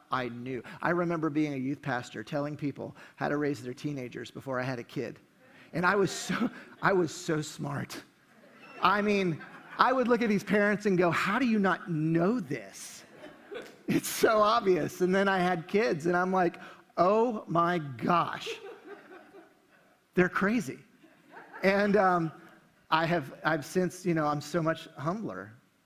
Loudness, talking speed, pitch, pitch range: -29 LUFS, 165 wpm, 175 Hz, 150-195 Hz